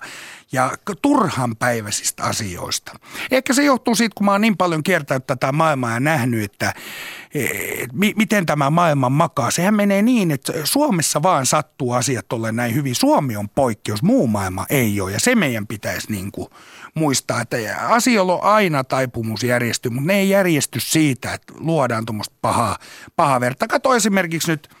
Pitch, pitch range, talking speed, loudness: 150 Hz, 125-195 Hz, 170 wpm, -19 LUFS